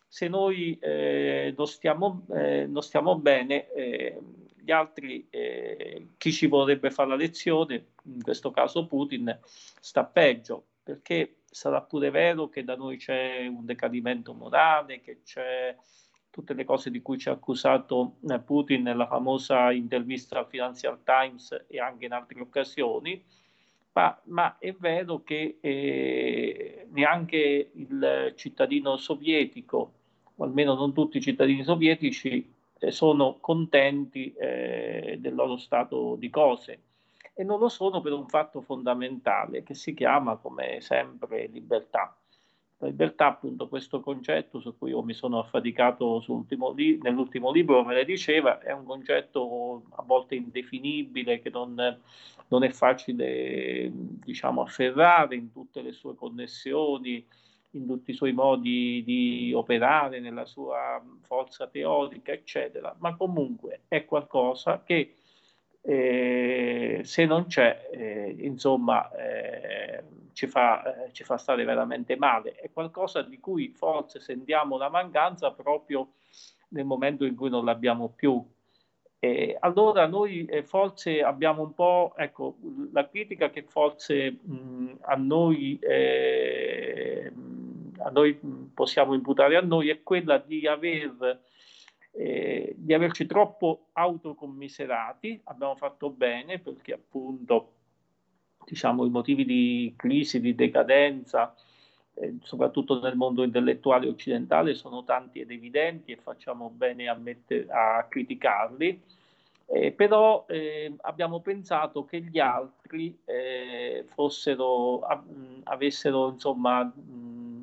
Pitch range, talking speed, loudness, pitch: 125-185 Hz, 130 wpm, -27 LUFS, 145 Hz